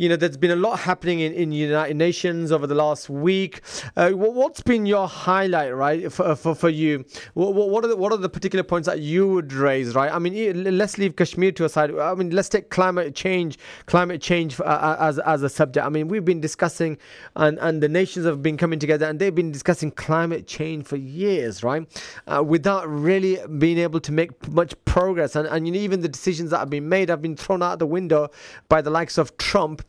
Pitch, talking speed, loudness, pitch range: 170 Hz, 225 wpm, -22 LUFS, 155-185 Hz